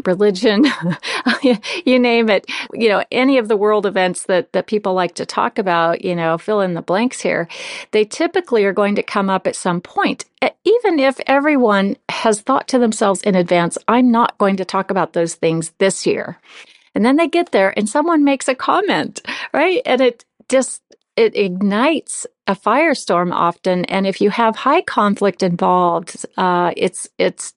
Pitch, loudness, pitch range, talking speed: 210 Hz, -16 LUFS, 185-265 Hz, 180 wpm